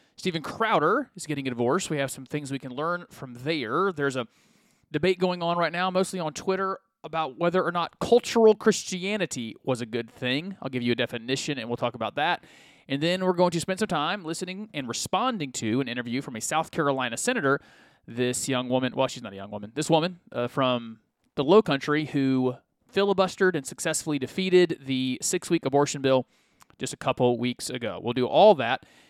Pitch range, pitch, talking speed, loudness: 130-185 Hz, 150 Hz, 200 wpm, -26 LUFS